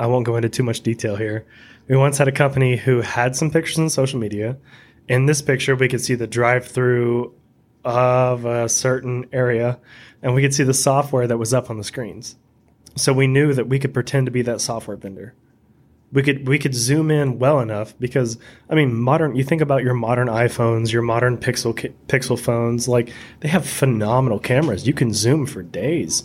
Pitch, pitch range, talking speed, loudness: 125 Hz, 115-135 Hz, 205 wpm, -19 LUFS